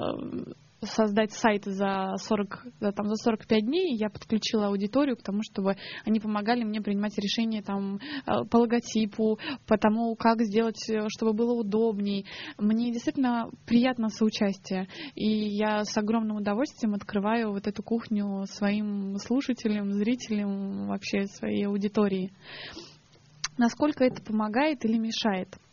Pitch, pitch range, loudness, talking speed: 215 Hz, 205-230 Hz, -28 LUFS, 125 wpm